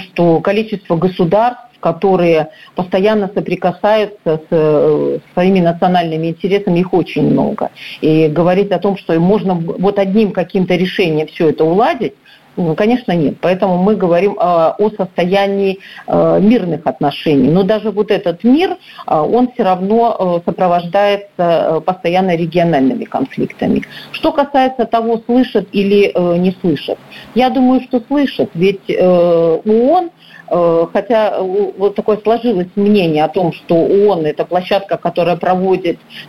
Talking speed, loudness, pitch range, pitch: 120 wpm, -13 LUFS, 170-210 Hz, 190 Hz